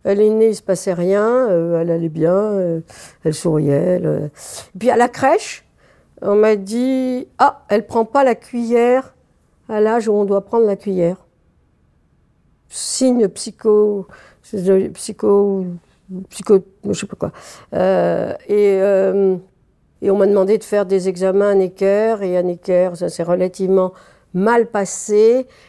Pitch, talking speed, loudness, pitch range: 200 Hz, 155 wpm, -17 LUFS, 185-215 Hz